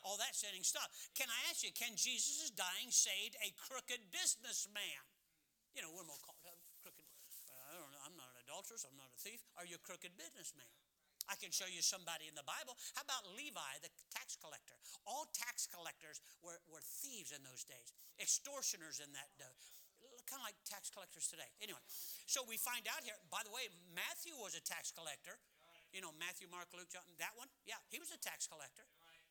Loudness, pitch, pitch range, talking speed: -45 LUFS, 185 Hz, 165-230 Hz, 200 wpm